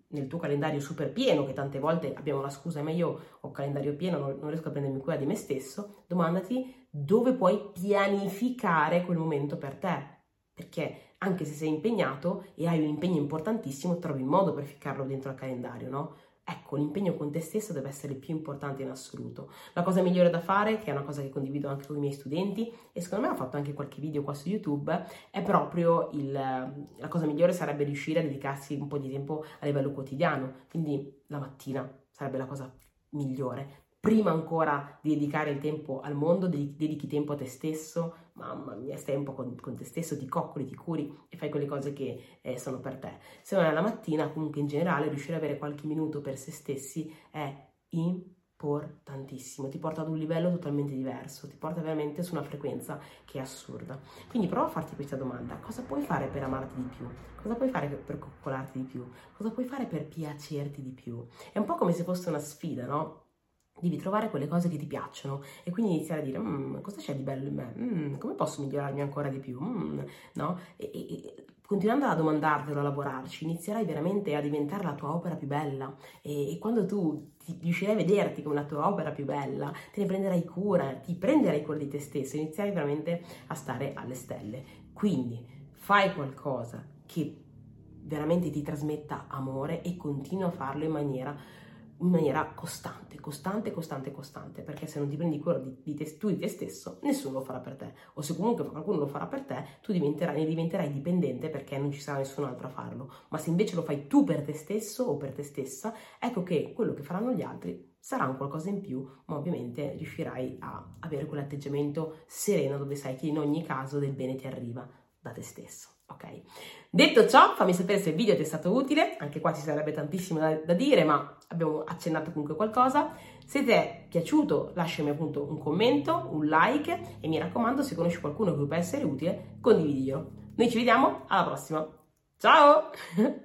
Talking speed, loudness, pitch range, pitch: 205 wpm, -31 LUFS, 140-175 Hz, 150 Hz